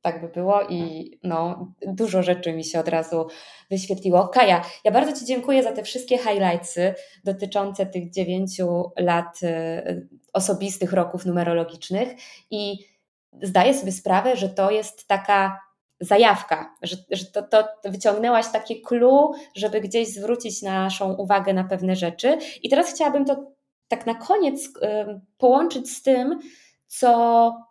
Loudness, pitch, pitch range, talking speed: -22 LUFS, 200 Hz, 180-235 Hz, 135 wpm